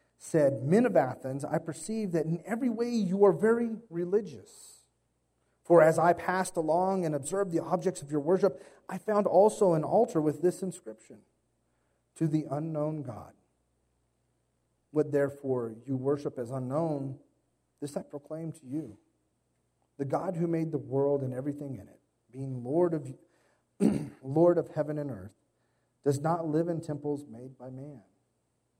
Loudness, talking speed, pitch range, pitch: -29 LUFS, 155 wpm, 125-175 Hz, 150 Hz